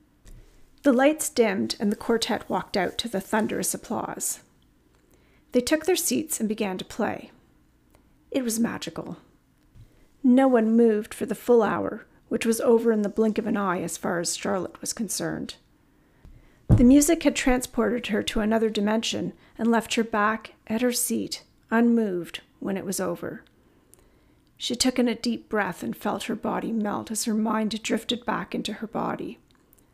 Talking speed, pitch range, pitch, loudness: 170 wpm, 210-240 Hz, 225 Hz, -25 LUFS